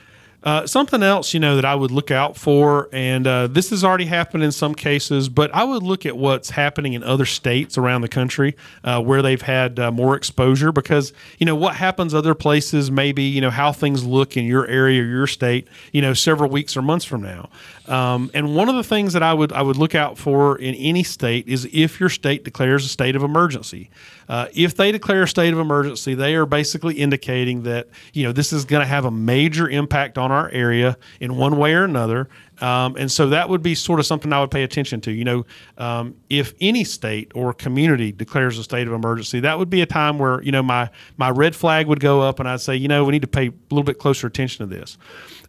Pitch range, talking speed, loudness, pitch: 125-155 Hz, 240 wpm, -19 LUFS, 140 Hz